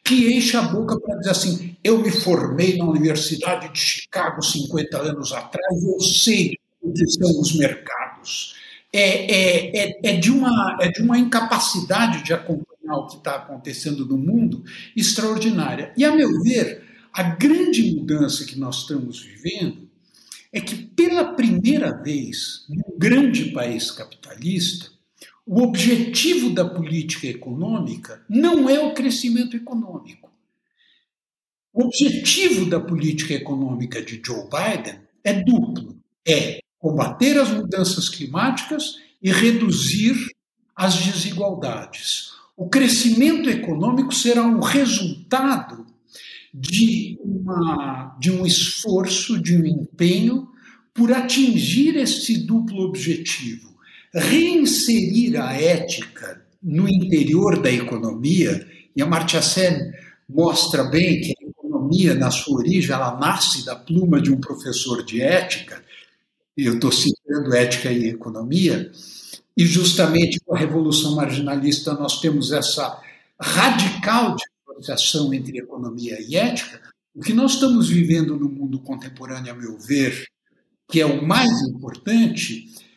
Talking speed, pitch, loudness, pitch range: 125 wpm, 185 Hz, -19 LUFS, 155-235 Hz